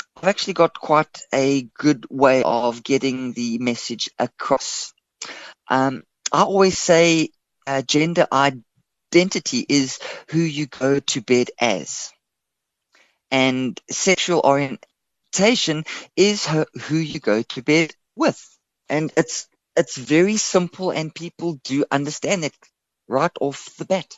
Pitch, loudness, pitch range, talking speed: 150 Hz, -20 LUFS, 130-170 Hz, 125 wpm